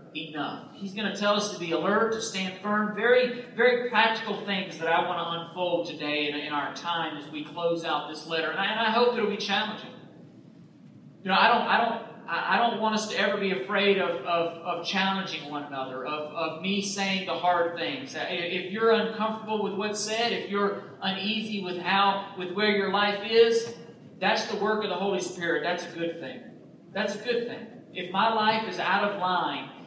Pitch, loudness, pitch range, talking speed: 195 Hz, -27 LUFS, 170-215 Hz, 210 wpm